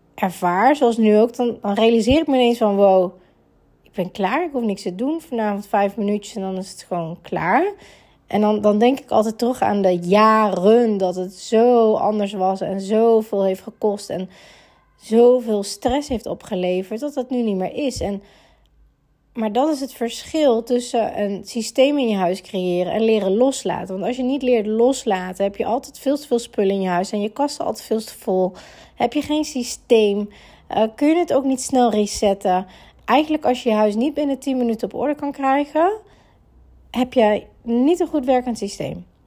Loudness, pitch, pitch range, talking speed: -19 LUFS, 220 Hz, 200-255 Hz, 195 wpm